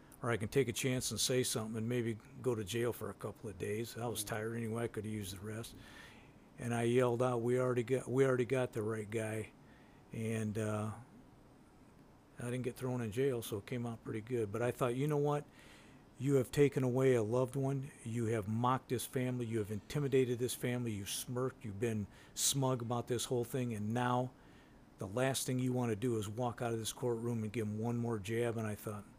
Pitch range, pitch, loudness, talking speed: 110-130 Hz, 120 Hz, -37 LUFS, 230 wpm